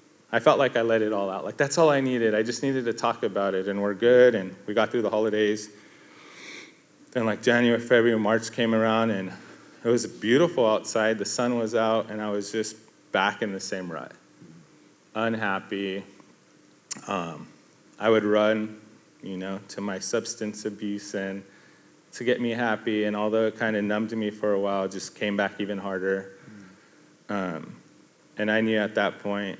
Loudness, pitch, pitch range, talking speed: -25 LUFS, 105 Hz, 100-115 Hz, 190 wpm